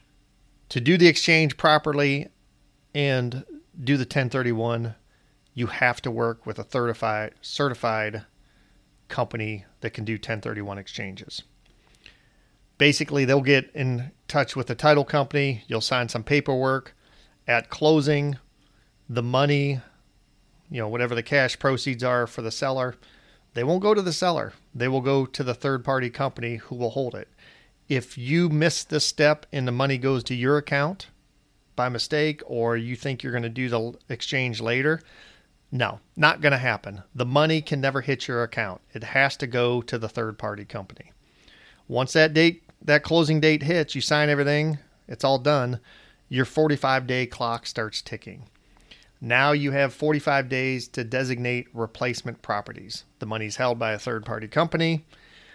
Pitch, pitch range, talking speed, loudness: 130 Hz, 120-145 Hz, 155 wpm, -24 LUFS